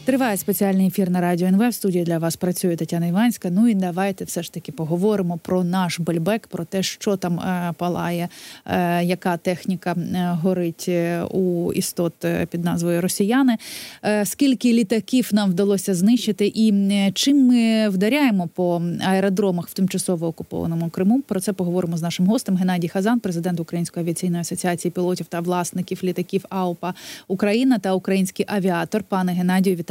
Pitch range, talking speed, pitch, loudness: 175-205 Hz, 160 wpm, 185 Hz, -21 LUFS